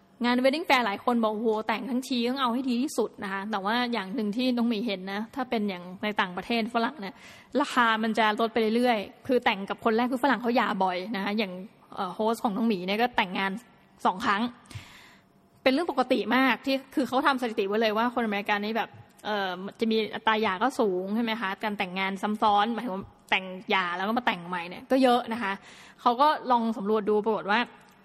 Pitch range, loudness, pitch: 205-245 Hz, -27 LUFS, 225 Hz